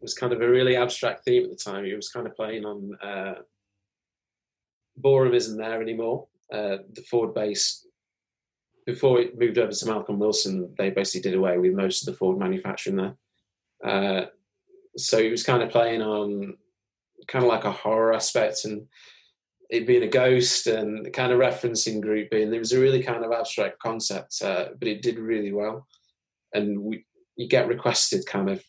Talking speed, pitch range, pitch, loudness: 190 wpm, 105-130 Hz, 115 Hz, -24 LUFS